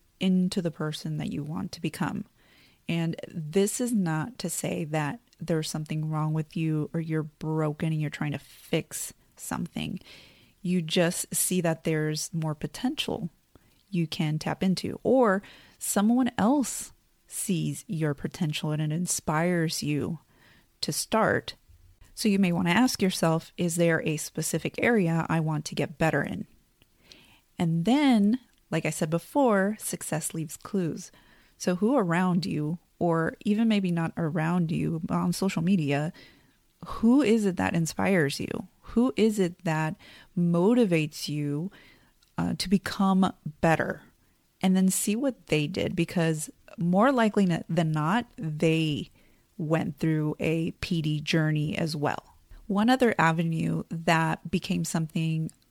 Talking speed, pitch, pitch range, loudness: 145 wpm, 170 Hz, 155-190 Hz, -27 LUFS